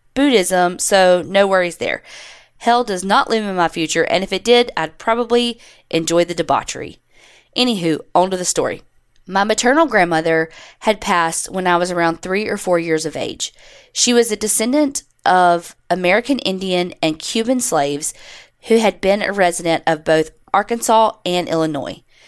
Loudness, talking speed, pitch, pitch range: -17 LUFS, 165 wpm, 185 Hz, 170-225 Hz